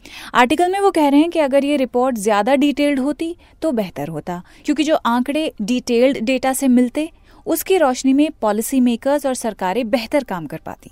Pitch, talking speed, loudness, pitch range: 265 Hz, 185 wpm, -18 LUFS, 235-295 Hz